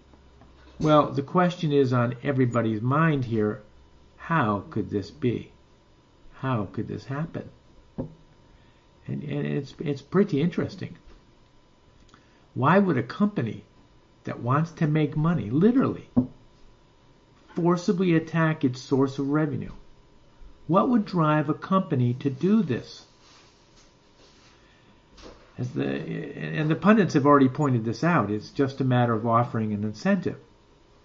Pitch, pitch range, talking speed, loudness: 140 Hz, 115-165 Hz, 125 wpm, -25 LUFS